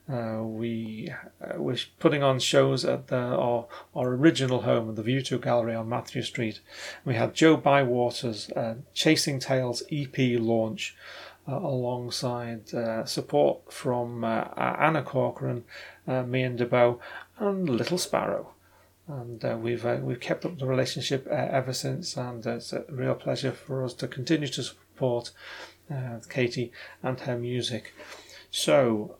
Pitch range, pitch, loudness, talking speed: 120-135 Hz, 125 Hz, -28 LUFS, 150 wpm